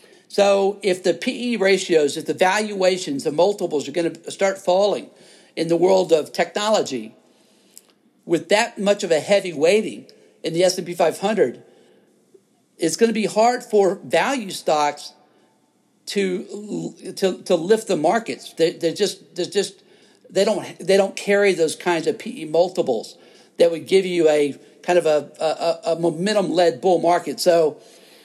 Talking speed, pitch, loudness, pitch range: 165 wpm, 185 Hz, -20 LUFS, 165-200 Hz